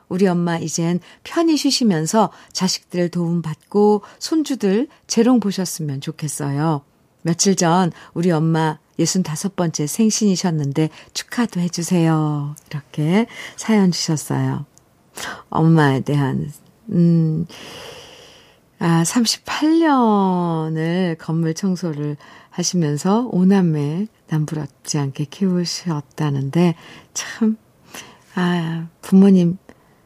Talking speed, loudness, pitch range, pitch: 200 characters per minute, -19 LUFS, 155-200 Hz, 170 Hz